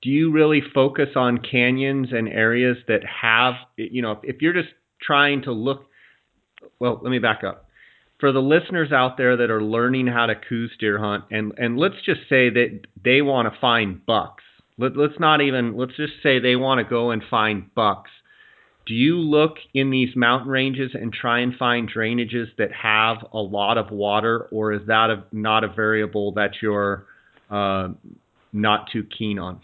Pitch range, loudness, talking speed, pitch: 110-135 Hz, -21 LUFS, 190 wpm, 120 Hz